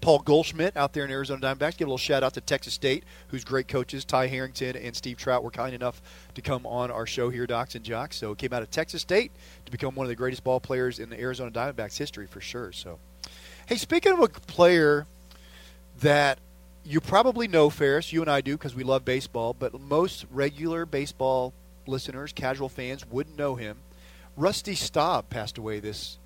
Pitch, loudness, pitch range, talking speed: 130 Hz, -27 LUFS, 115-145 Hz, 210 wpm